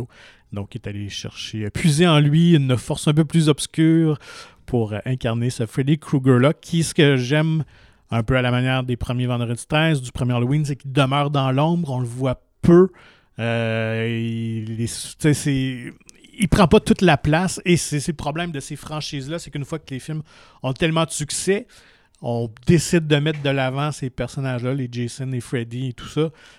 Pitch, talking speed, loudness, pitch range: 135 Hz, 190 wpm, -20 LUFS, 120-155 Hz